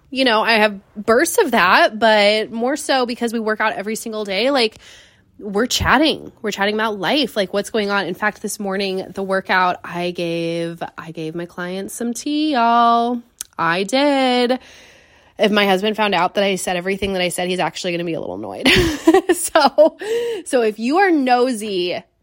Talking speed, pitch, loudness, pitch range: 190 wpm, 215 Hz, -18 LUFS, 190-255 Hz